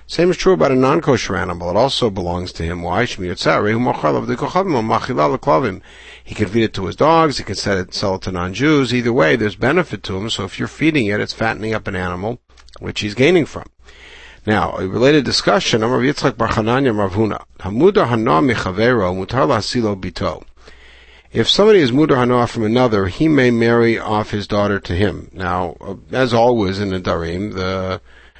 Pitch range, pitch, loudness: 95-125 Hz, 110 Hz, -17 LUFS